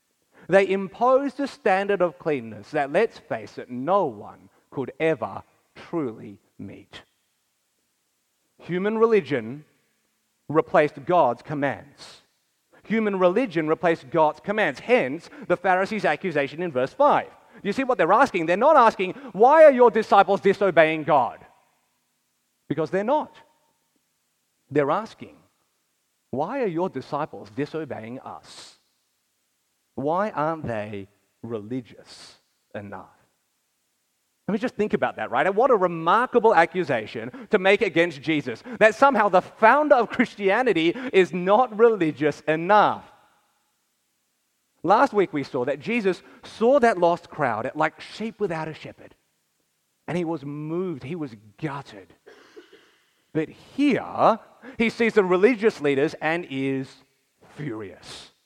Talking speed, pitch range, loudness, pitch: 125 wpm, 150-225 Hz, -22 LUFS, 180 Hz